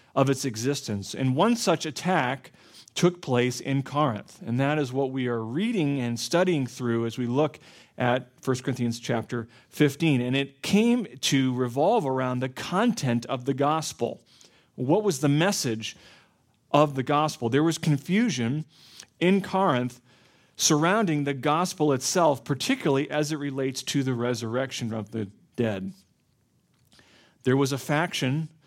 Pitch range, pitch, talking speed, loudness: 125-155 Hz, 135 Hz, 145 wpm, -26 LUFS